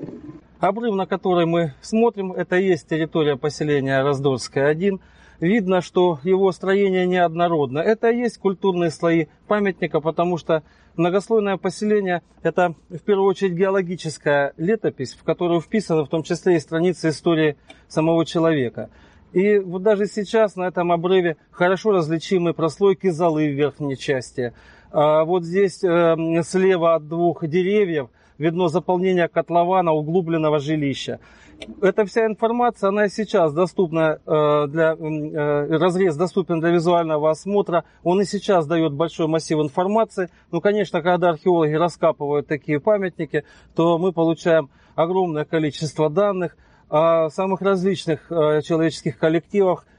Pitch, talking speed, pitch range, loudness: 170 Hz, 130 wpm, 155-190 Hz, -20 LUFS